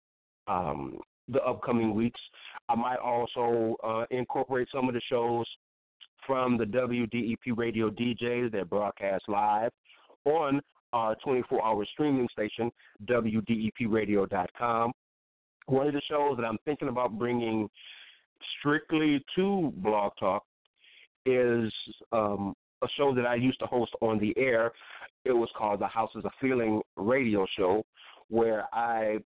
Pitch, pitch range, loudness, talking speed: 115 Hz, 110-125 Hz, -30 LUFS, 130 wpm